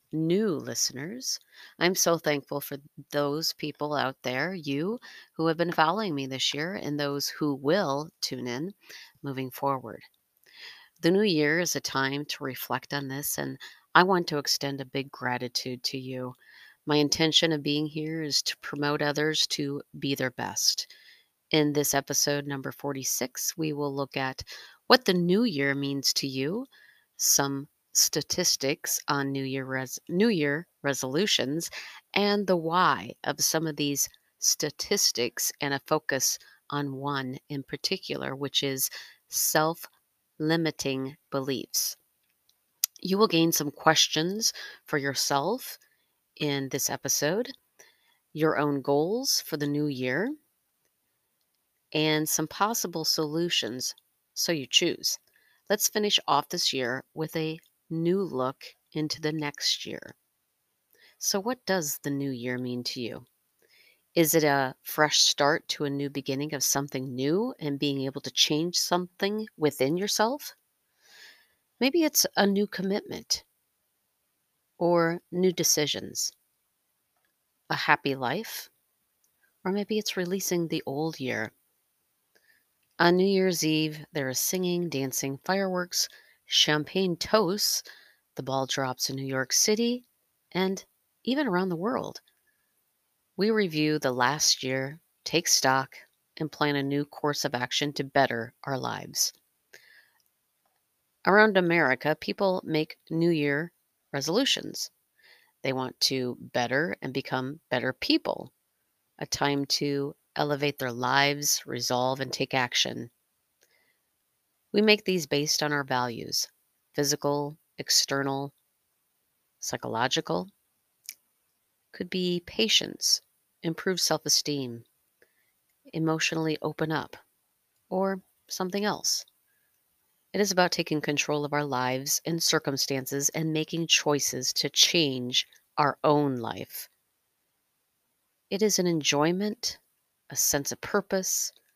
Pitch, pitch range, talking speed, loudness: 150 Hz, 140-175 Hz, 125 wpm, -27 LUFS